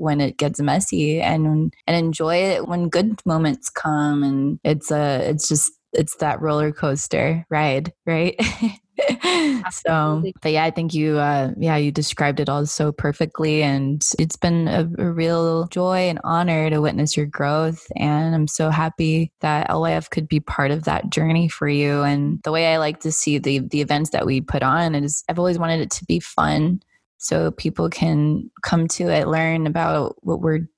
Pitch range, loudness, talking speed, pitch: 145-165 Hz, -20 LUFS, 185 wpm, 155 Hz